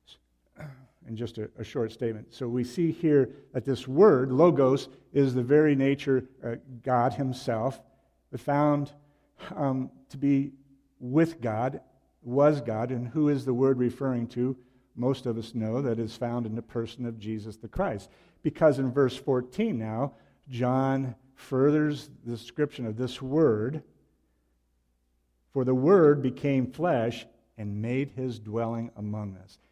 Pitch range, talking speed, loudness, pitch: 115-140 Hz, 150 wpm, -27 LUFS, 130 Hz